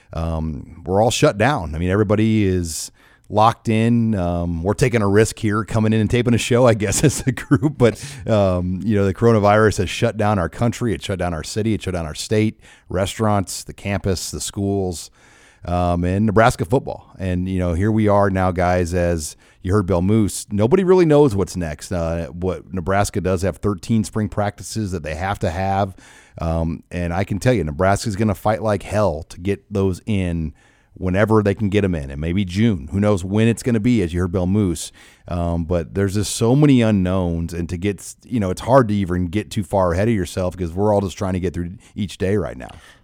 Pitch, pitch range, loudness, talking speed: 100 Hz, 90-110 Hz, -19 LUFS, 225 wpm